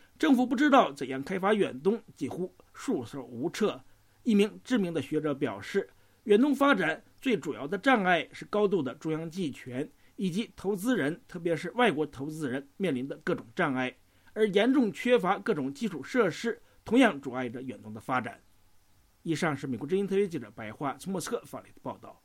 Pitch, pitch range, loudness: 175 Hz, 135-215 Hz, -29 LUFS